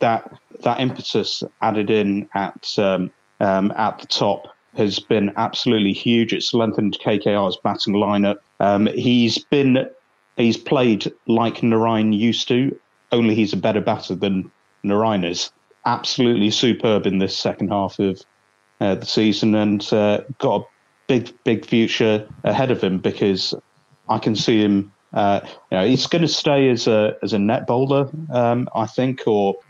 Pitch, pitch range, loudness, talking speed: 110 Hz, 100-120 Hz, -19 LUFS, 160 wpm